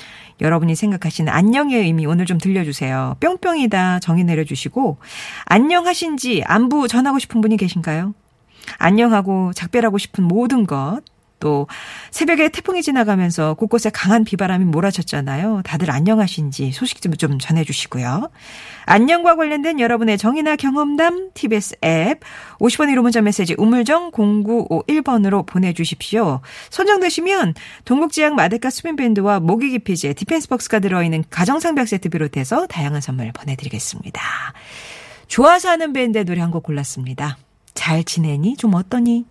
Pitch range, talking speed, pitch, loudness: 160-250 Hz, 350 characters per minute, 205 Hz, -17 LUFS